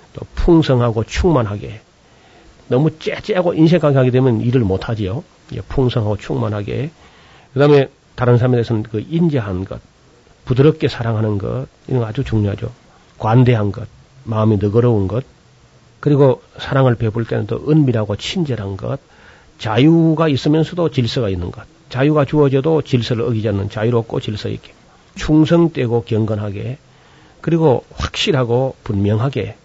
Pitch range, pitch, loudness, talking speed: 110-145 Hz, 125 Hz, -16 LUFS, 320 characters per minute